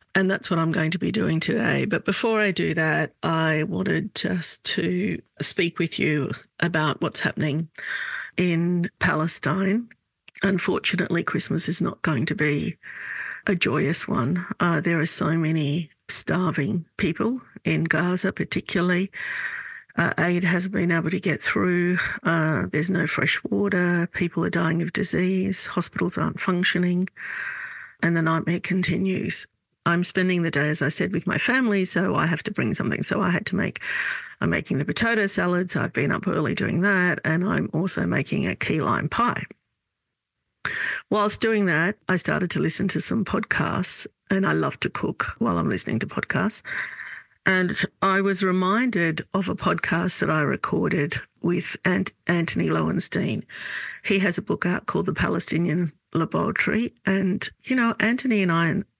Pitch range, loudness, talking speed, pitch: 165-195 Hz, -23 LUFS, 165 wpm, 180 Hz